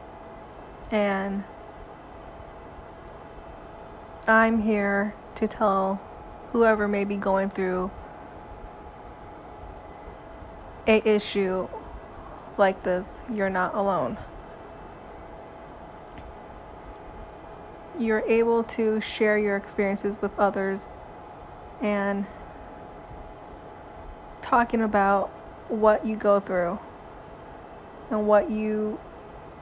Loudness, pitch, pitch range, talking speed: -25 LUFS, 205 Hz, 195-220 Hz, 70 wpm